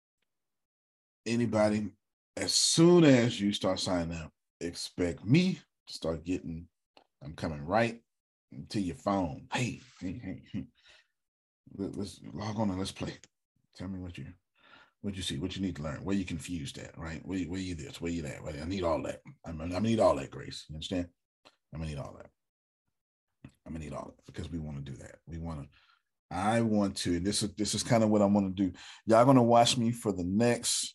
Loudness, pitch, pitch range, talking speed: -30 LUFS, 95 Hz, 80-105 Hz, 205 wpm